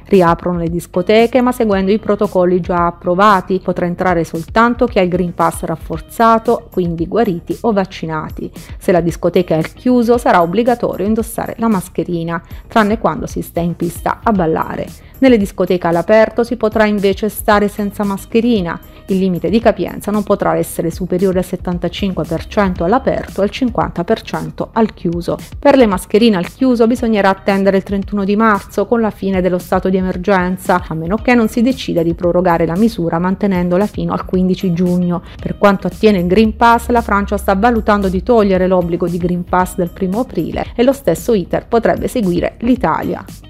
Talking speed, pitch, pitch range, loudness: 170 wpm, 195 Hz, 180-220 Hz, -14 LUFS